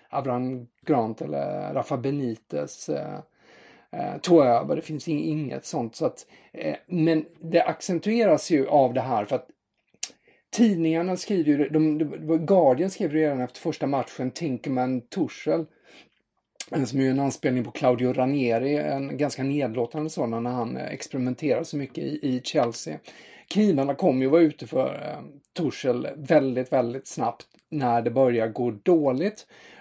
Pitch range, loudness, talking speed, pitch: 125-160 Hz, -25 LUFS, 145 wpm, 140 Hz